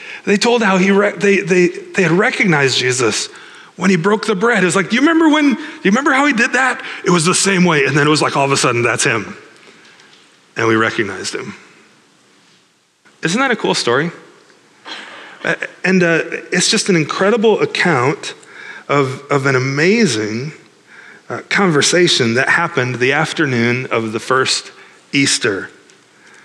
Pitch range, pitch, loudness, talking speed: 140-230 Hz, 185 Hz, -14 LUFS, 170 wpm